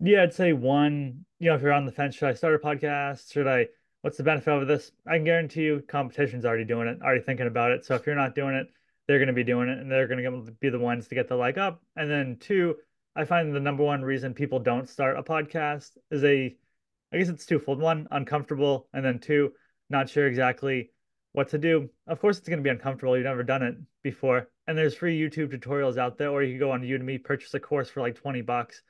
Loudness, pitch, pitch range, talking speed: -27 LUFS, 140 Hz, 130-150 Hz, 255 wpm